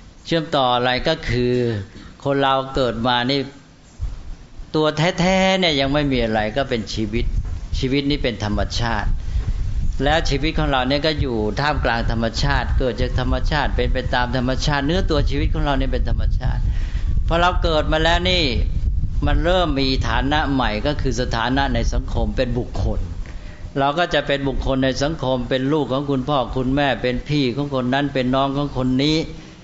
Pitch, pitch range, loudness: 130 Hz, 110-140 Hz, -20 LUFS